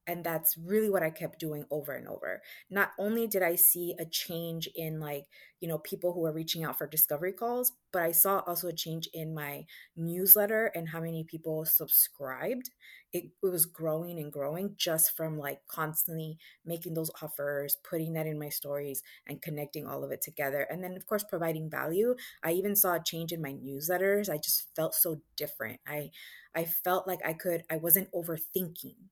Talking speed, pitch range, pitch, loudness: 195 wpm, 155-180 Hz, 165 Hz, -30 LUFS